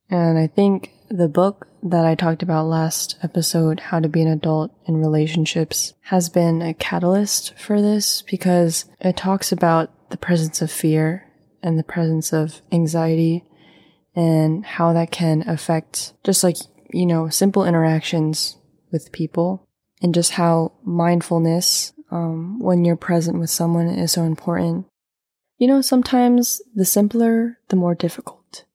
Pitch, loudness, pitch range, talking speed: 170 Hz, -19 LUFS, 160-185 Hz, 150 wpm